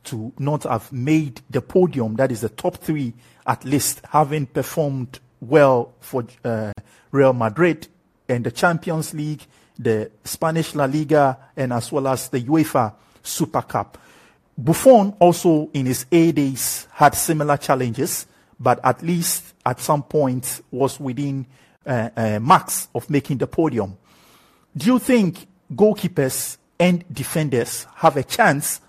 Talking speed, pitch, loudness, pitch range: 145 wpm, 140 Hz, -20 LUFS, 125-160 Hz